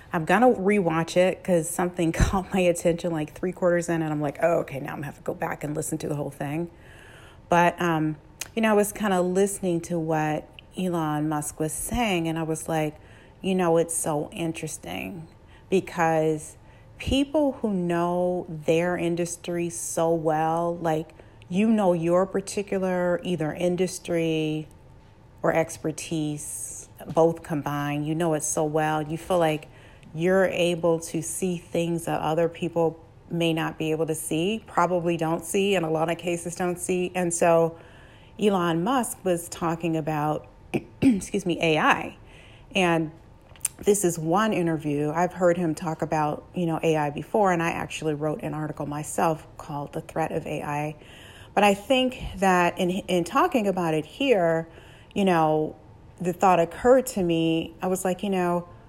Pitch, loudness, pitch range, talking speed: 165 Hz, -25 LUFS, 155-180 Hz, 165 wpm